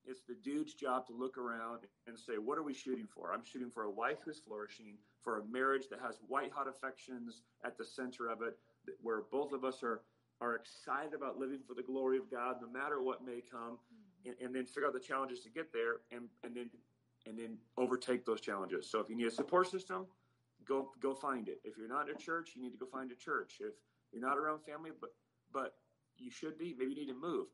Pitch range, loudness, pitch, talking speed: 120-140 Hz, -42 LUFS, 125 Hz, 240 wpm